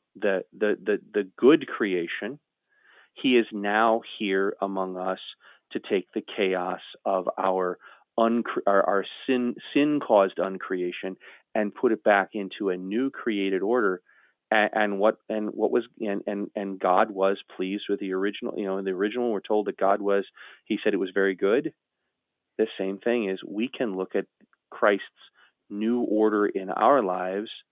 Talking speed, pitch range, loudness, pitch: 170 wpm, 95-110 Hz, -26 LUFS, 100 Hz